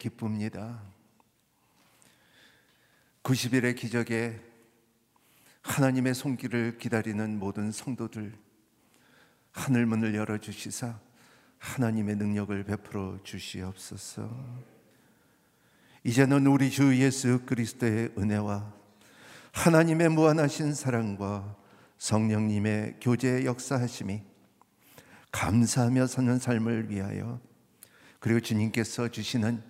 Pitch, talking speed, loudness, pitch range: 115 Hz, 220 characters per minute, -29 LUFS, 105-125 Hz